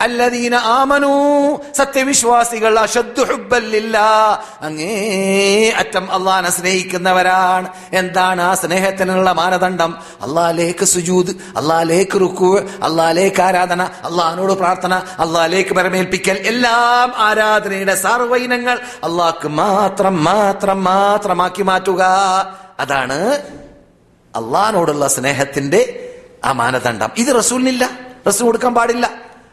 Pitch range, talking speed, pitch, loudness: 185-235 Hz, 80 wpm, 195 Hz, -14 LUFS